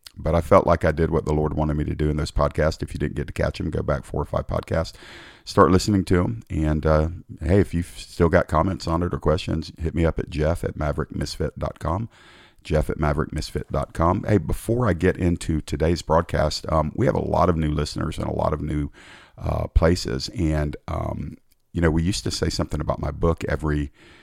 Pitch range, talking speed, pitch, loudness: 75-90 Hz, 225 wpm, 80 Hz, -23 LUFS